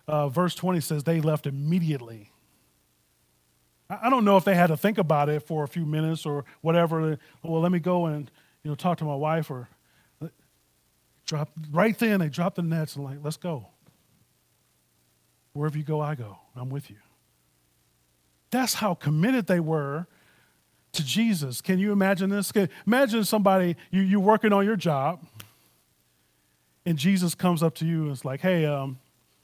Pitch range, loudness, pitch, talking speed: 120-180 Hz, -25 LUFS, 155 Hz, 175 wpm